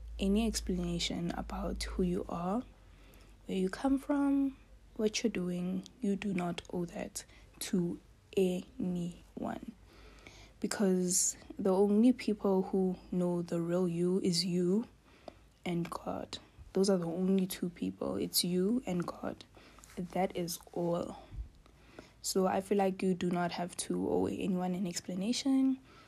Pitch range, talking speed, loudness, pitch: 180-205 Hz, 135 wpm, -34 LUFS, 185 Hz